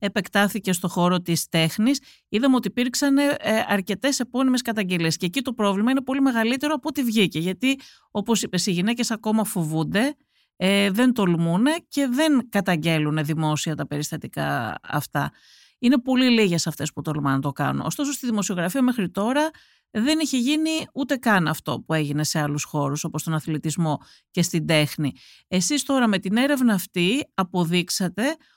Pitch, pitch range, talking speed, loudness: 205 Hz, 165-260 Hz, 160 wpm, -23 LUFS